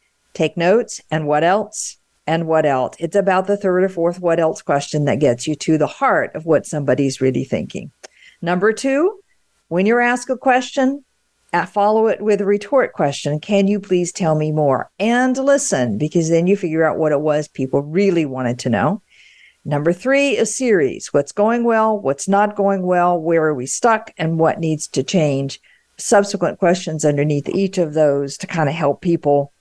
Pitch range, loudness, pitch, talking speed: 150-205 Hz, -18 LUFS, 175 Hz, 190 wpm